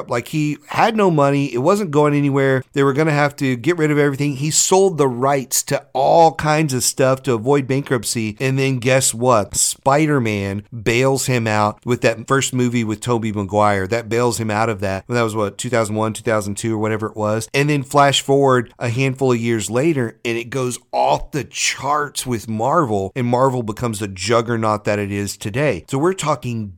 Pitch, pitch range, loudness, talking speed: 125 Hz, 115-140 Hz, -18 LUFS, 205 wpm